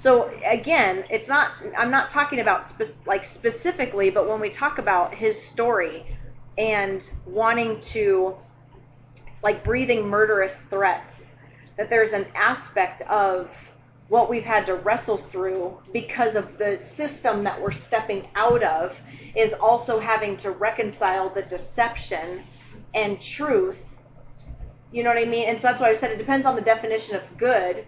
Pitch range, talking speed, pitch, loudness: 190-235 Hz, 155 wpm, 215 Hz, -23 LUFS